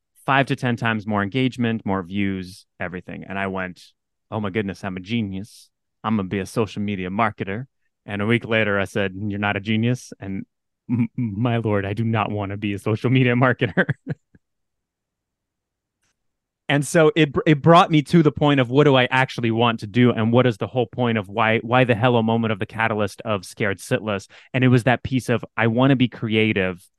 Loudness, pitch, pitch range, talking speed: -21 LUFS, 115 Hz, 100-125 Hz, 205 wpm